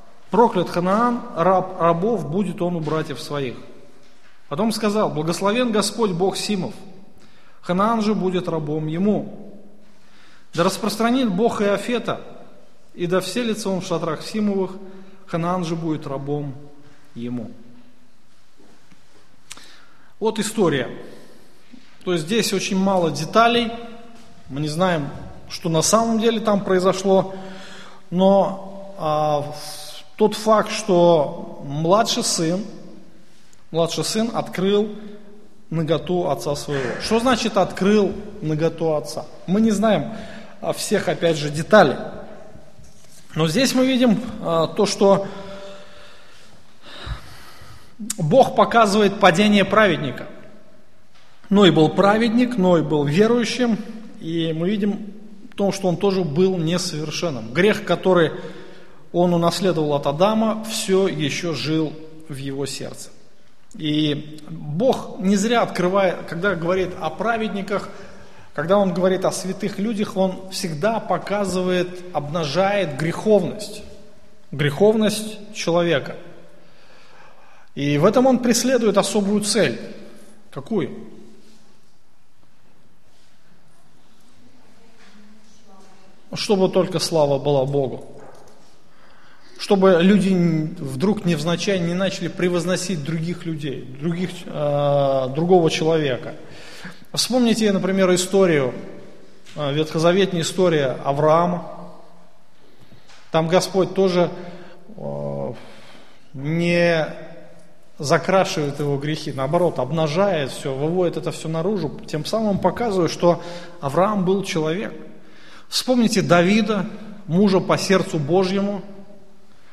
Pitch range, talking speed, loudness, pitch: 160-205 Hz, 100 wpm, -20 LUFS, 185 Hz